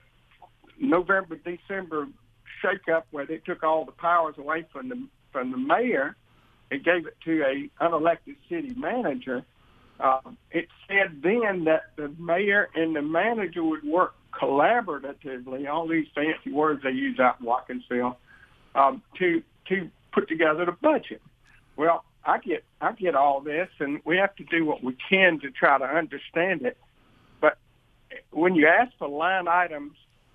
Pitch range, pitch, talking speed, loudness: 145-195 Hz, 165 Hz, 155 wpm, -25 LUFS